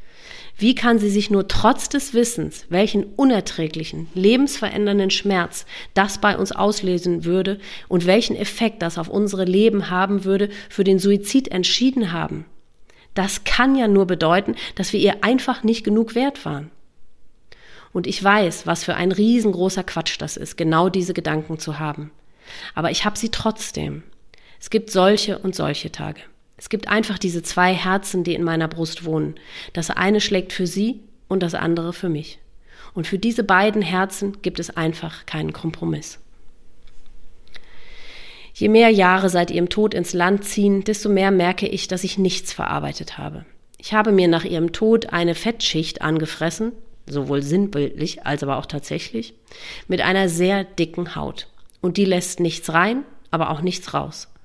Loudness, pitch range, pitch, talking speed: -20 LUFS, 170-210 Hz, 190 Hz, 165 wpm